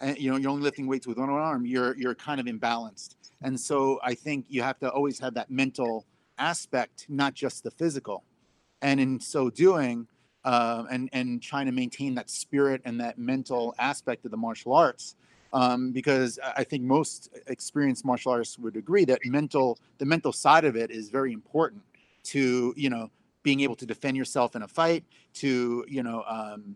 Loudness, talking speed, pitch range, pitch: -28 LUFS, 195 wpm, 120-140 Hz, 130 Hz